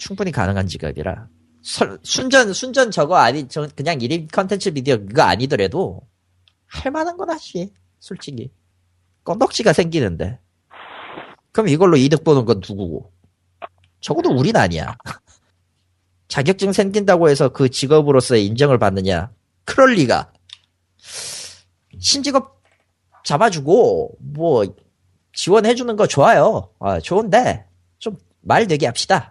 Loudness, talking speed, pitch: -17 LUFS, 265 characters per minute, 115 Hz